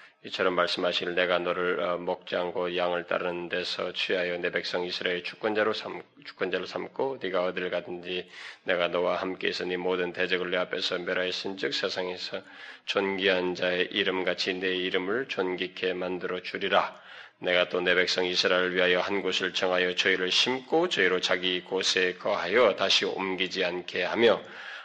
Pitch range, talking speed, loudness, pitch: 90-95 Hz, 340 characters per minute, -27 LUFS, 90 Hz